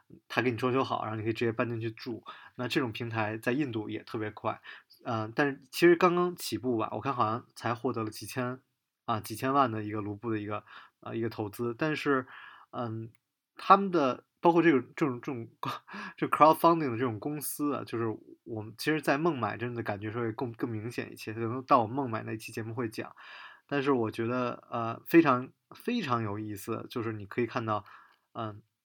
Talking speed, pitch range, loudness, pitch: 325 characters per minute, 110-135 Hz, -31 LUFS, 120 Hz